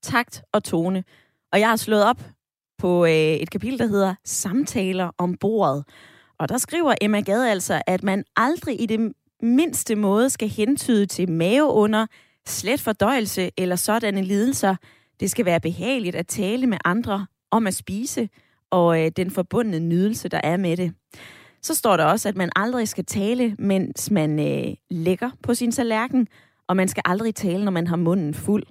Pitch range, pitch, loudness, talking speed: 180-230 Hz, 200 Hz, -22 LUFS, 180 wpm